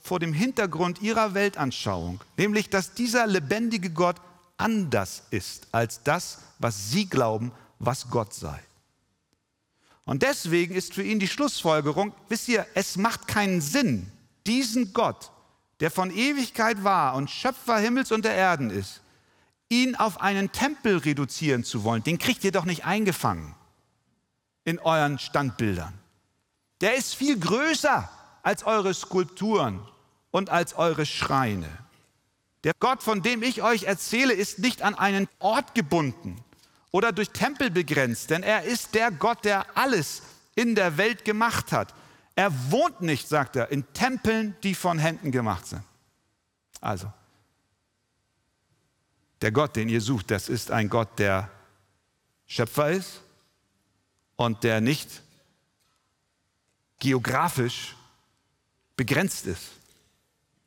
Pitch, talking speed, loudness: 160 Hz, 130 wpm, -26 LUFS